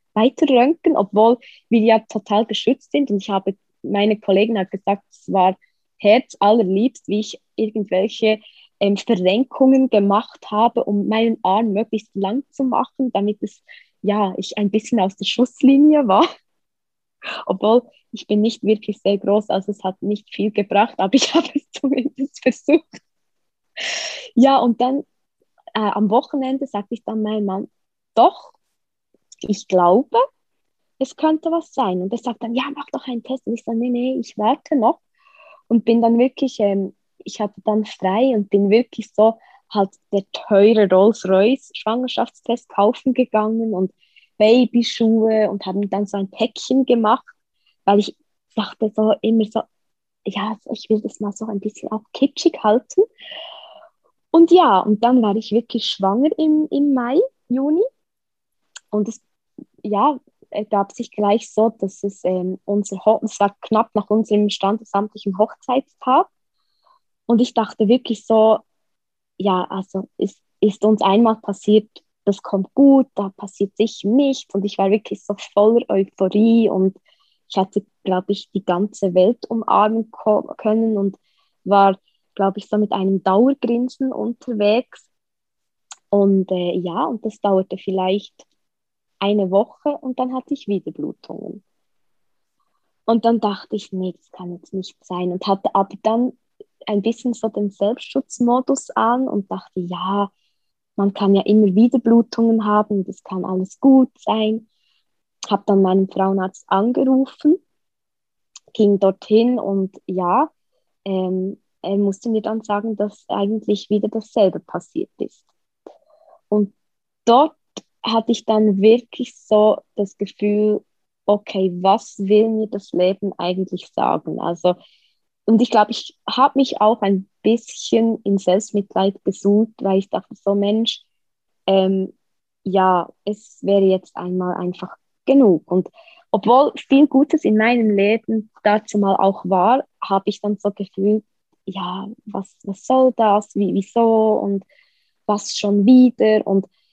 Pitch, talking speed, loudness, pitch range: 215 Hz, 150 wpm, -18 LUFS, 200-245 Hz